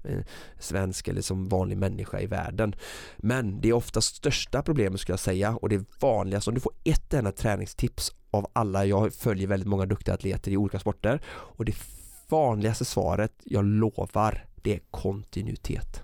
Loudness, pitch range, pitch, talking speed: -28 LUFS, 95-110 Hz, 100 Hz, 170 wpm